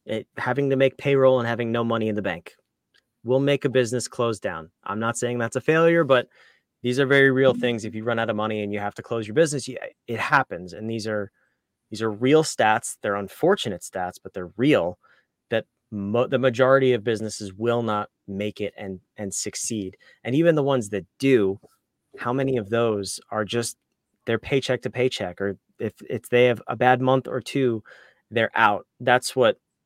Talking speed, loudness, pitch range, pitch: 205 wpm, -23 LUFS, 105-130 Hz, 120 Hz